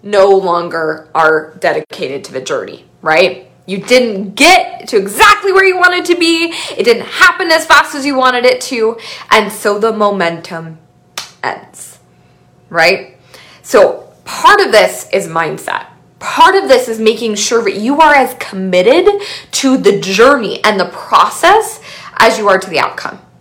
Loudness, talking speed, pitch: -10 LUFS, 160 wpm, 250 Hz